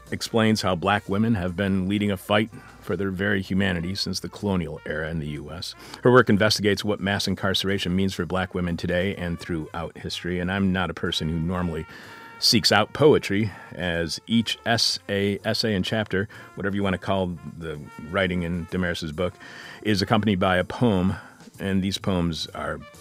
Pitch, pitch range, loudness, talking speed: 95 Hz, 90-105 Hz, -24 LUFS, 180 wpm